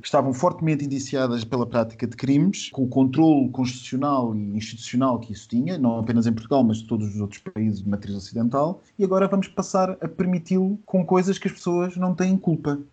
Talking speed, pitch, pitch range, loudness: 205 wpm, 140 Hz, 115-185 Hz, -23 LUFS